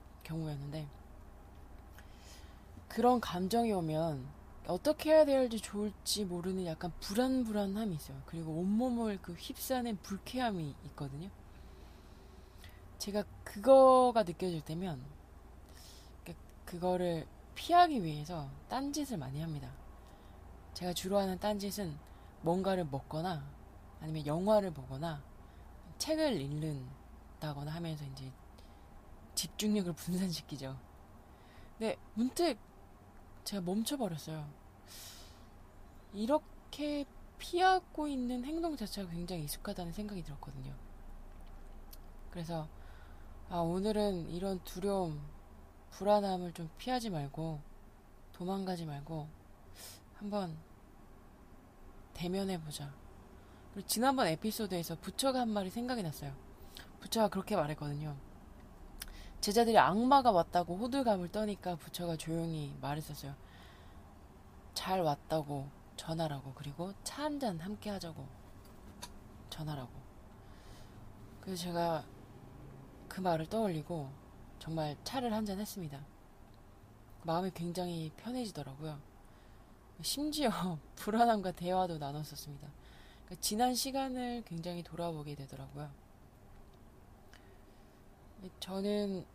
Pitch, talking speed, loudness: 160 Hz, 240 characters per minute, -36 LUFS